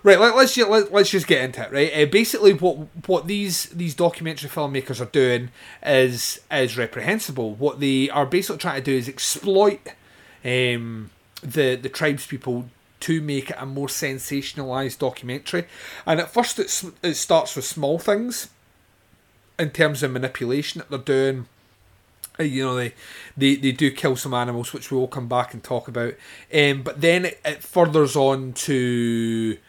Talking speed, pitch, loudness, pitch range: 170 wpm, 140 Hz, -21 LUFS, 125-165 Hz